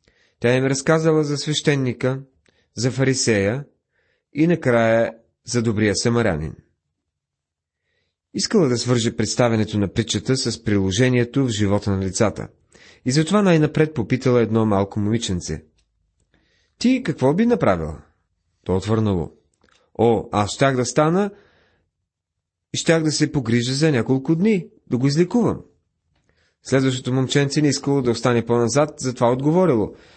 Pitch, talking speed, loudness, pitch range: 125 Hz, 125 wpm, -20 LUFS, 105-145 Hz